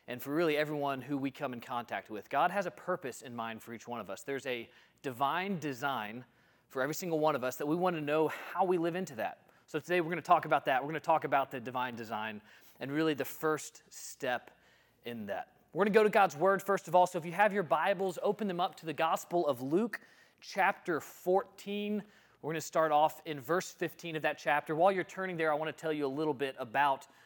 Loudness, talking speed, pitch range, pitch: -33 LUFS, 250 wpm, 135-180 Hz, 155 Hz